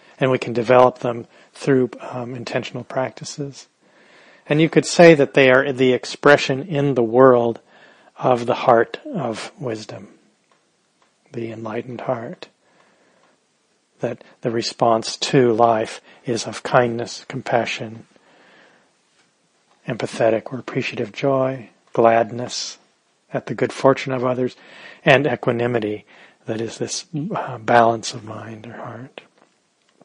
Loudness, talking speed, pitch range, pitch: -19 LUFS, 120 wpm, 115-135 Hz, 125 Hz